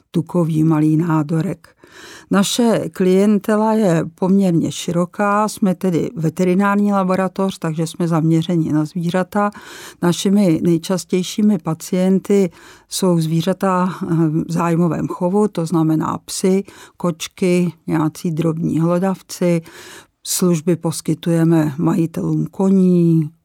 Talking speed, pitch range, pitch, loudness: 90 wpm, 165-190 Hz, 175 Hz, -17 LUFS